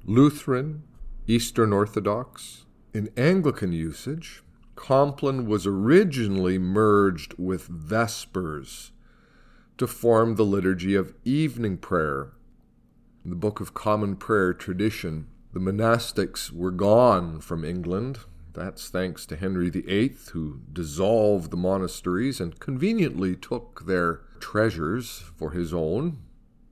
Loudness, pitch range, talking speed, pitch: -25 LUFS, 90-115 Hz, 110 wpm, 100 Hz